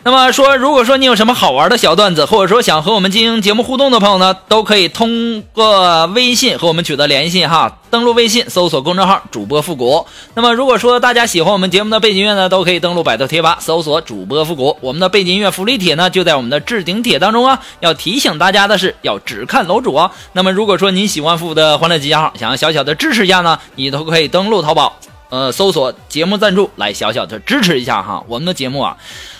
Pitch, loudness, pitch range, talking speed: 190 Hz, -11 LUFS, 165-230 Hz, 375 characters per minute